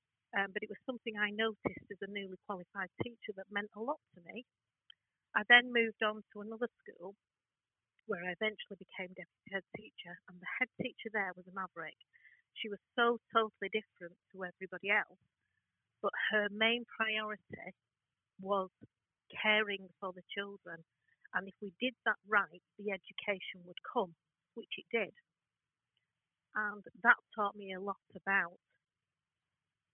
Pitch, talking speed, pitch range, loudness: 200 Hz, 155 wpm, 185-220 Hz, -36 LUFS